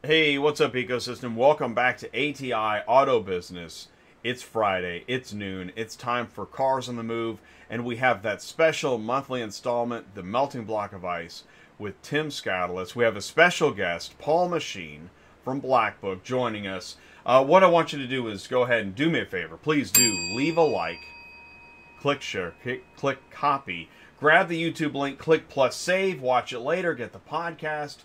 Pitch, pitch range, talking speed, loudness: 120 Hz, 95-140 Hz, 180 wpm, -25 LUFS